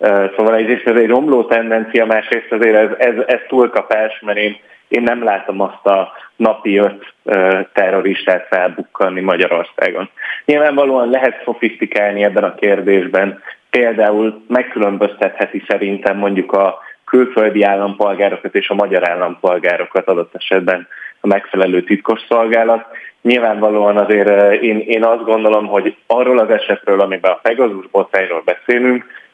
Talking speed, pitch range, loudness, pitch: 120 wpm, 100-115 Hz, -14 LUFS, 105 Hz